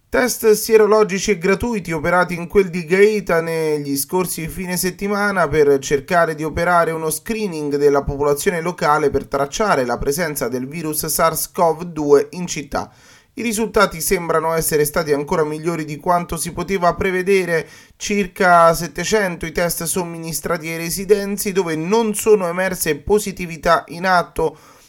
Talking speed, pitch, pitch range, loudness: 135 wpm, 175 Hz, 160-195 Hz, -18 LUFS